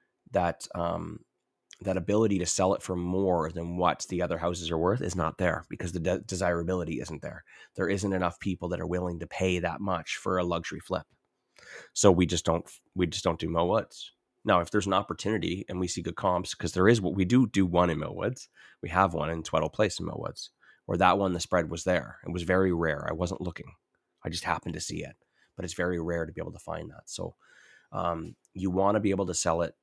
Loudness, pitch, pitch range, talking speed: -29 LUFS, 90 Hz, 85-95 Hz, 235 wpm